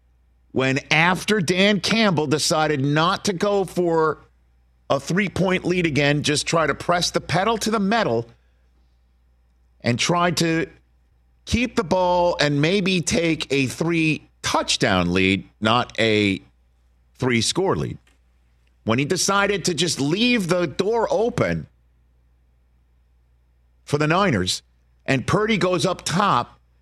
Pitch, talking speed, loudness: 140 Hz, 130 wpm, -20 LUFS